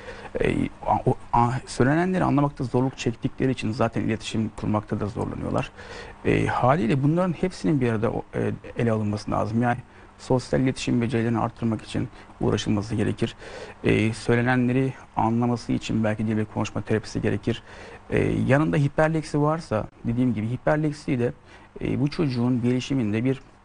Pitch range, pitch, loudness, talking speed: 110-130 Hz, 120 Hz, -25 LUFS, 125 wpm